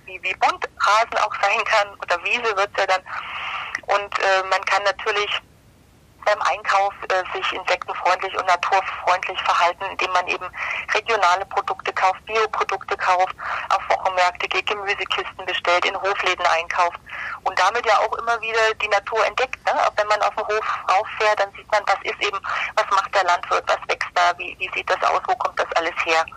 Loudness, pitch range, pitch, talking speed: -21 LUFS, 185-210 Hz, 195 Hz, 185 wpm